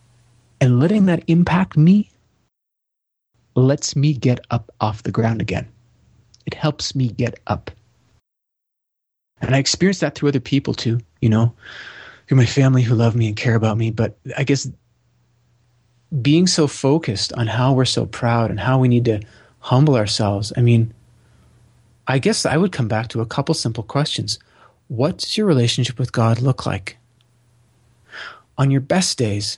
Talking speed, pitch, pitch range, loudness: 160 wpm, 120 Hz, 115-140 Hz, -18 LUFS